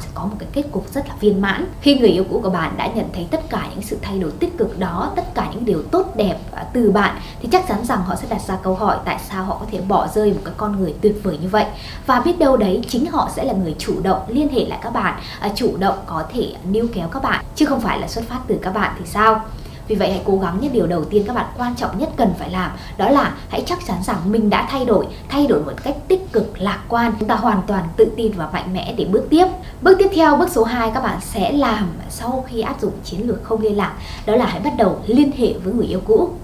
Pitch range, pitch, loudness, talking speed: 200-265 Hz, 220 Hz, -19 LUFS, 285 wpm